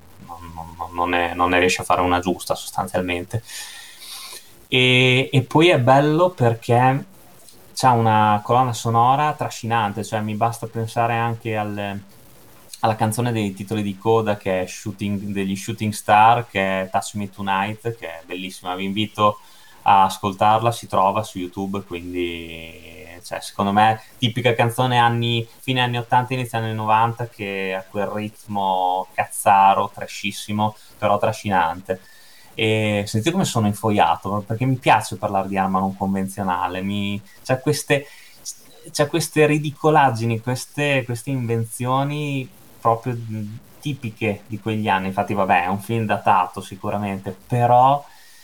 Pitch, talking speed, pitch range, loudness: 110 Hz, 135 wpm, 100-120 Hz, -20 LUFS